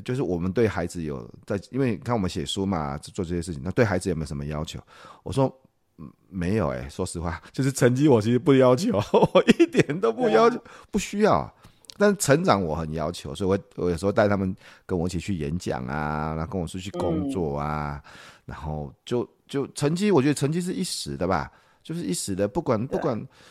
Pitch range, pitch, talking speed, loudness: 80-135 Hz, 95 Hz, 310 characters per minute, -25 LUFS